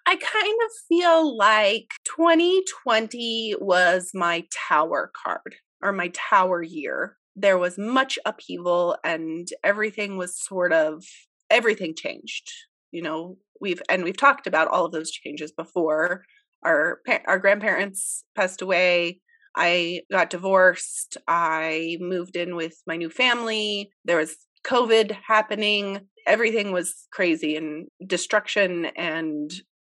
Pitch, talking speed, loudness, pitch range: 190 Hz, 125 wpm, -23 LUFS, 170-225 Hz